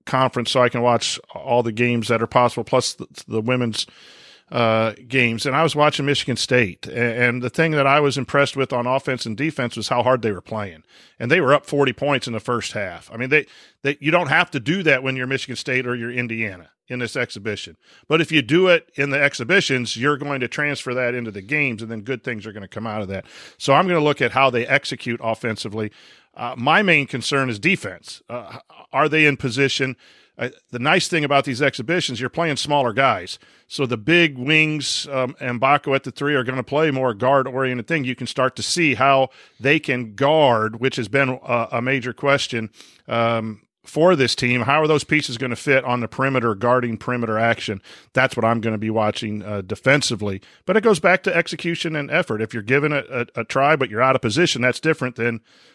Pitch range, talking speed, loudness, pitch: 115-145 Hz, 230 wpm, -20 LUFS, 130 Hz